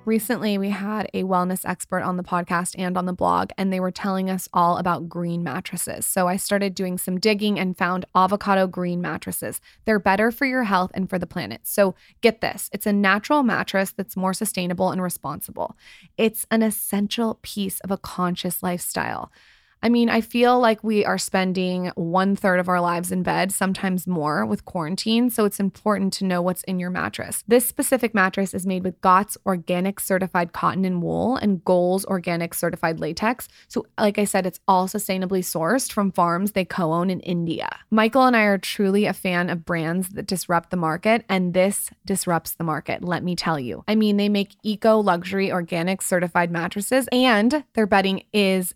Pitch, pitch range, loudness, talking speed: 190 Hz, 180-205 Hz, -22 LUFS, 195 wpm